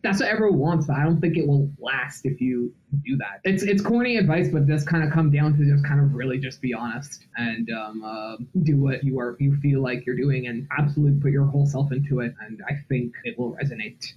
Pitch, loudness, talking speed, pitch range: 140 Hz, -23 LUFS, 250 wpm, 125-150 Hz